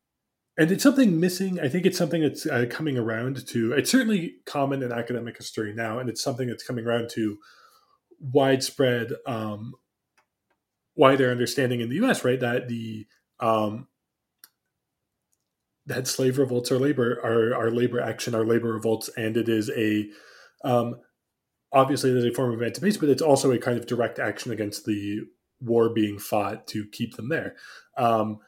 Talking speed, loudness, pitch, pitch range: 170 wpm, -25 LUFS, 120 Hz, 110-135 Hz